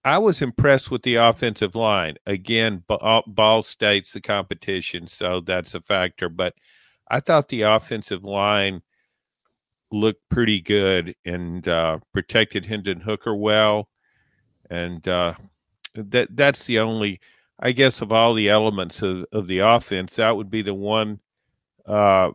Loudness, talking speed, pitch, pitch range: -21 LUFS, 140 wpm, 105 Hz, 95-115 Hz